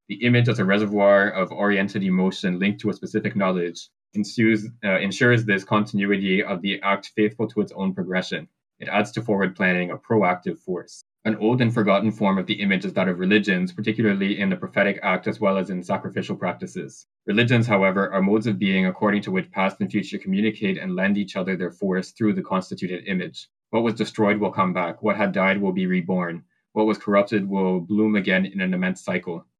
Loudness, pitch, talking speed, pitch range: -22 LUFS, 100 Hz, 205 wpm, 95-110 Hz